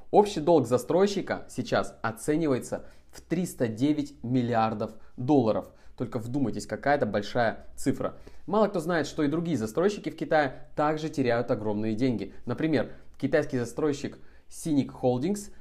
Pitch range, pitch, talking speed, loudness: 120-155 Hz, 135 Hz, 125 wpm, -28 LUFS